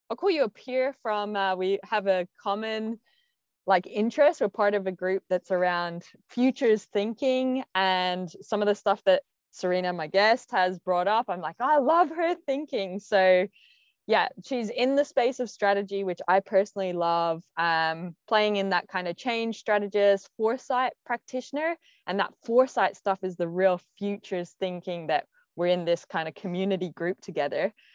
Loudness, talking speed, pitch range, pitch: -27 LUFS, 175 wpm, 185-245 Hz, 200 Hz